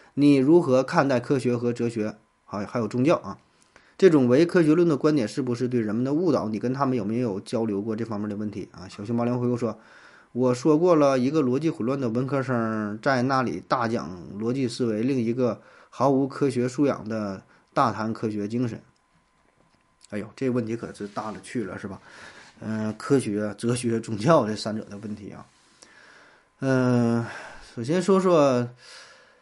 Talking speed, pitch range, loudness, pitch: 270 characters per minute, 110-130 Hz, -24 LUFS, 120 Hz